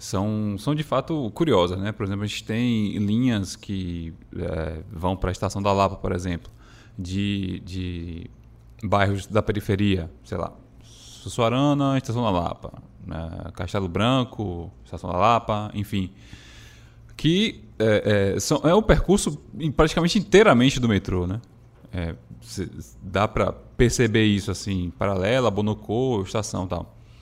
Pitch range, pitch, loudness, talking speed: 95-115 Hz, 105 Hz, -23 LUFS, 145 wpm